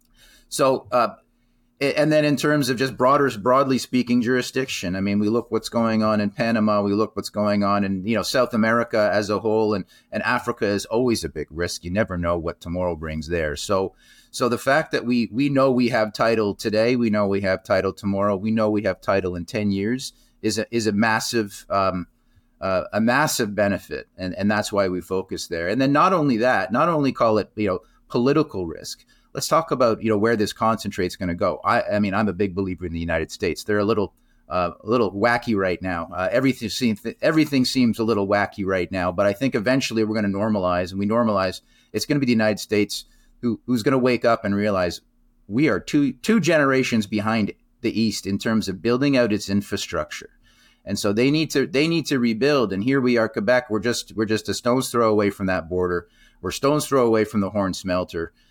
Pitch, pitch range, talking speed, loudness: 110 Hz, 100-120 Hz, 225 wpm, -22 LUFS